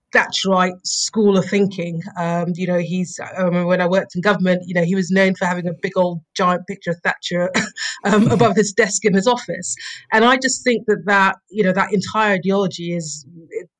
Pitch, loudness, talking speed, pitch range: 190 Hz, -18 LUFS, 215 wpm, 175-205 Hz